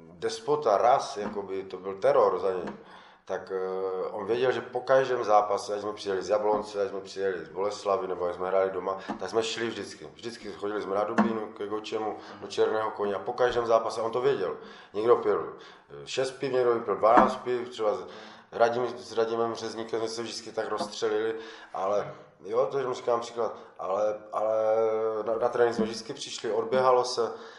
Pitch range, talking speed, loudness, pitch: 105-125 Hz, 185 wpm, -28 LUFS, 115 Hz